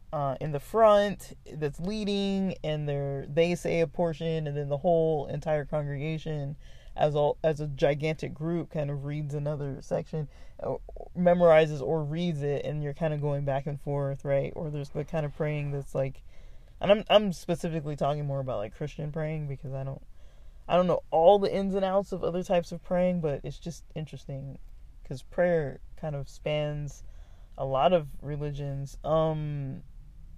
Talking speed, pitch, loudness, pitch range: 180 wpm, 150 Hz, -29 LUFS, 140-165 Hz